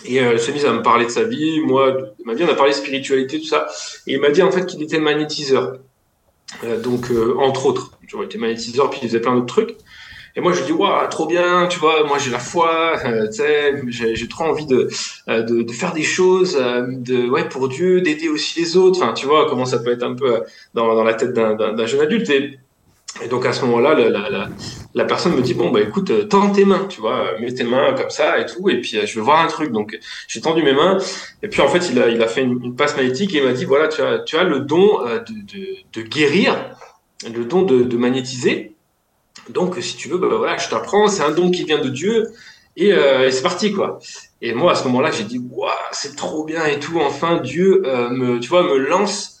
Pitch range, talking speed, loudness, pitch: 125-195 Hz, 265 wpm, -17 LUFS, 155 Hz